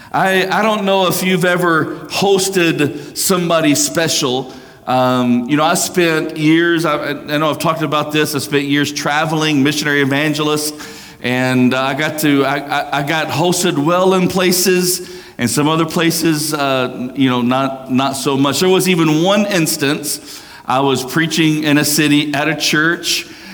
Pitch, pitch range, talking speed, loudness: 155 Hz, 140-170 Hz, 170 wpm, -14 LUFS